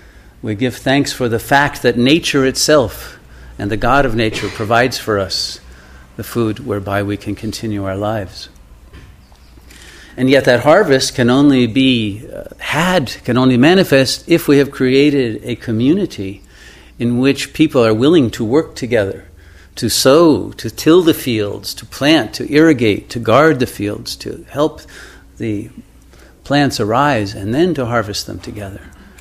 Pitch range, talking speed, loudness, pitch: 100-135 Hz, 155 wpm, -14 LUFS, 115 Hz